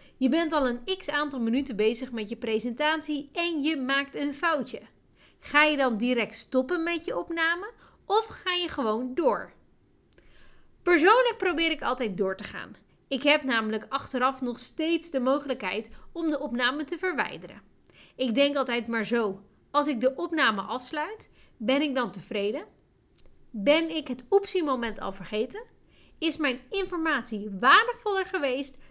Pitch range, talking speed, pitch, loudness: 240-330 Hz, 155 wpm, 275 Hz, -27 LUFS